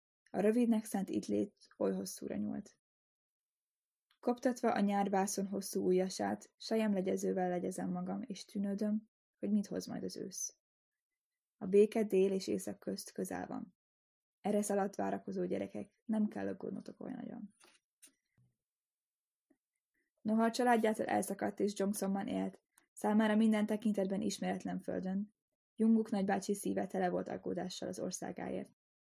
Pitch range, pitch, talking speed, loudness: 180-220 Hz, 200 Hz, 125 wpm, -36 LUFS